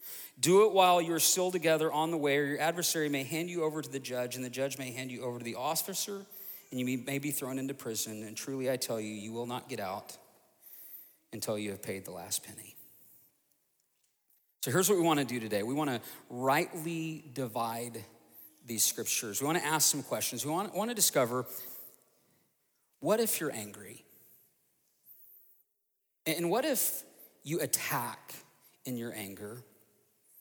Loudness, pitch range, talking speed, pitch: -32 LUFS, 120-160 Hz, 180 wpm, 135 Hz